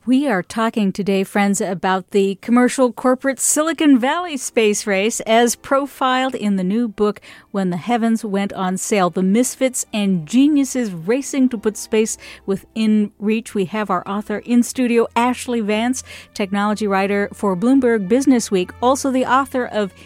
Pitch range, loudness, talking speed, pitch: 200-250 Hz, -18 LUFS, 160 wpm, 225 Hz